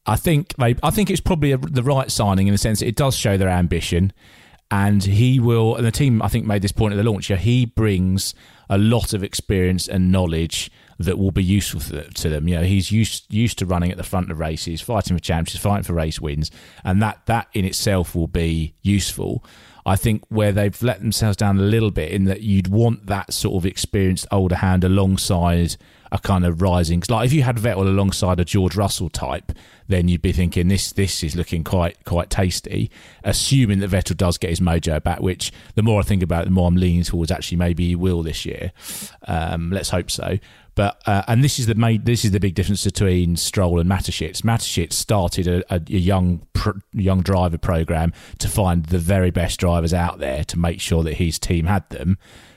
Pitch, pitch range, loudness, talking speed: 95 Hz, 85-105 Hz, -20 LUFS, 220 wpm